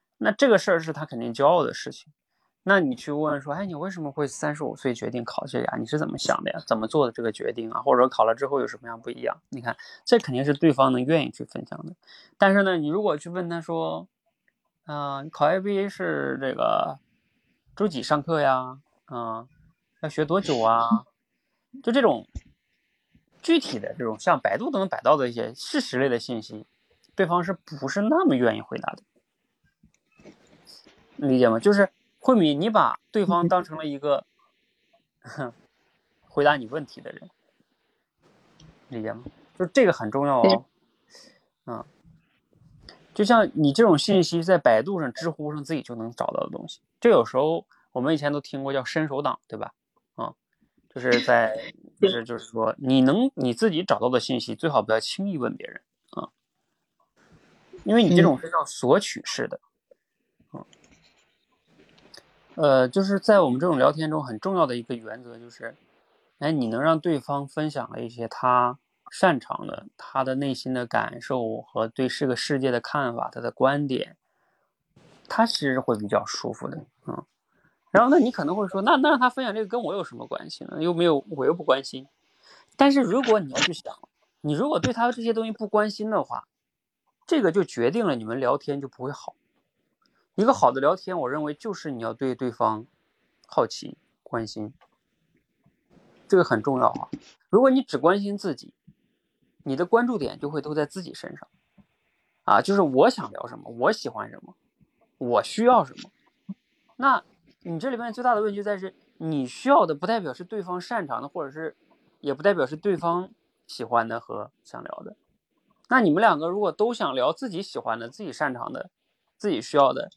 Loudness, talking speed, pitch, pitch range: -24 LUFS, 265 characters per minute, 155 Hz, 130-205 Hz